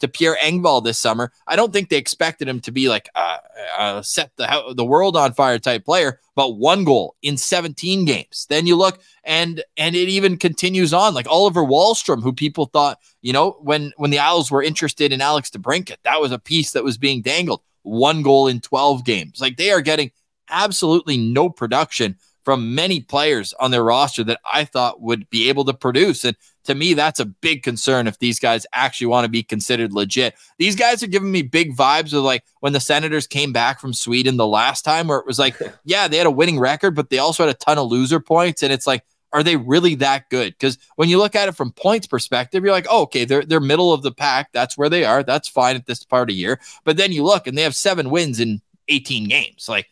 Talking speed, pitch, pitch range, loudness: 235 wpm, 145 Hz, 125-165 Hz, -17 LUFS